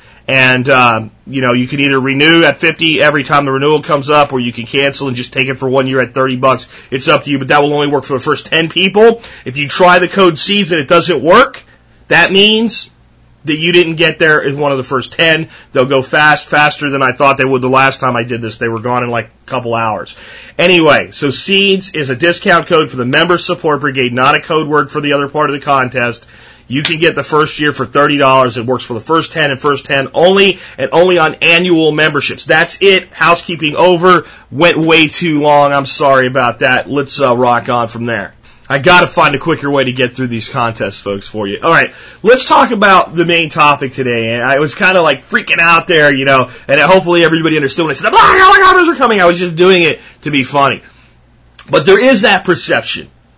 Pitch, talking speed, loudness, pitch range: 145 Hz, 245 wpm, -10 LUFS, 130-170 Hz